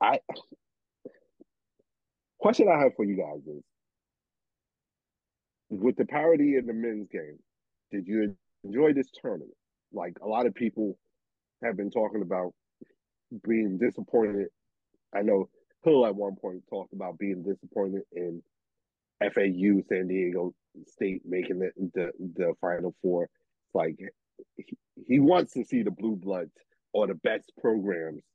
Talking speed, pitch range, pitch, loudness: 140 wpm, 95-130 Hz, 105 Hz, -29 LUFS